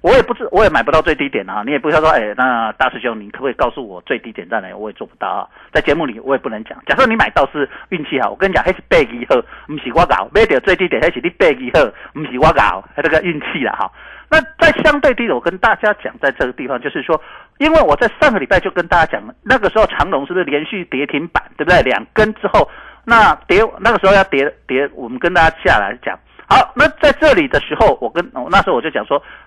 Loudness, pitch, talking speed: -14 LUFS, 215 Hz, 370 characters per minute